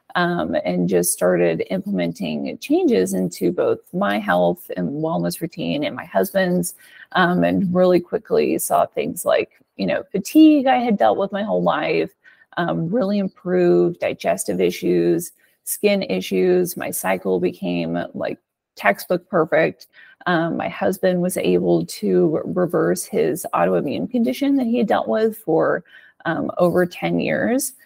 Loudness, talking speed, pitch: -20 LUFS, 140 wpm, 180 Hz